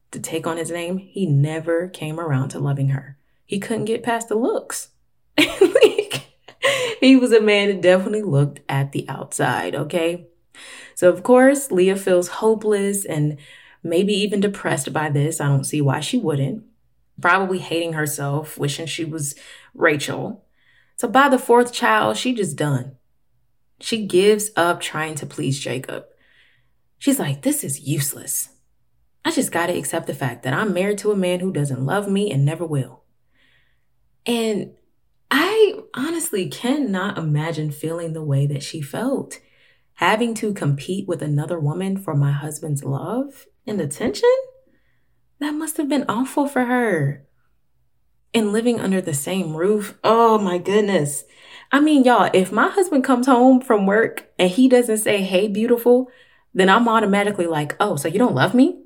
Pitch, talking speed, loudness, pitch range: 185 Hz, 165 wpm, -20 LUFS, 150-235 Hz